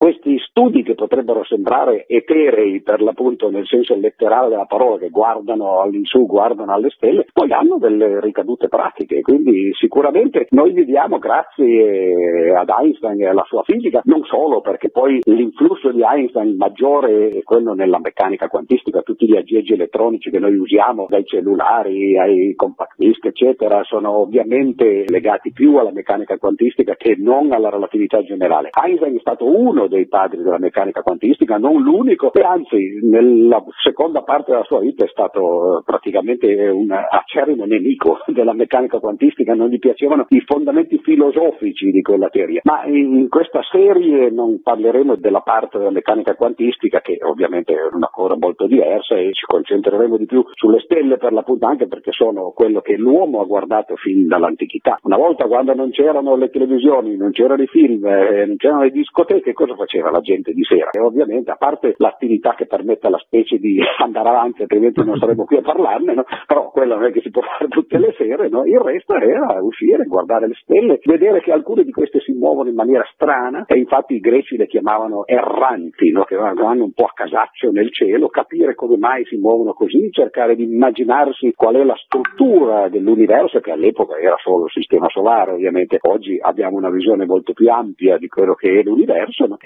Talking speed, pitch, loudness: 180 wpm, 335 Hz, -15 LUFS